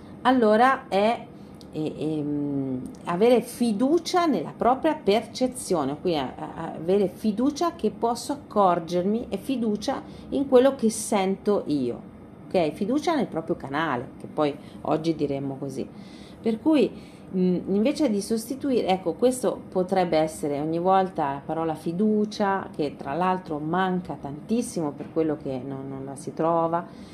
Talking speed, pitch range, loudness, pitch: 130 wpm, 160-235 Hz, -25 LUFS, 190 Hz